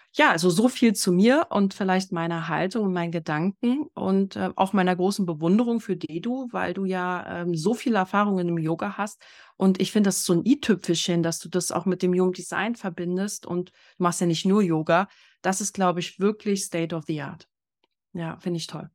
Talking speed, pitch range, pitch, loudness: 215 wpm, 175-205 Hz, 185 Hz, -24 LUFS